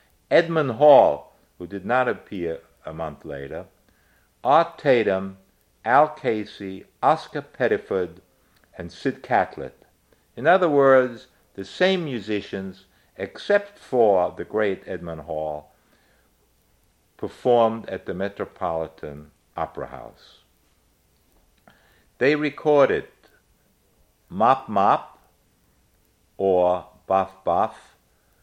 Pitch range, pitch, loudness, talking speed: 85-130 Hz, 95 Hz, -22 LUFS, 90 wpm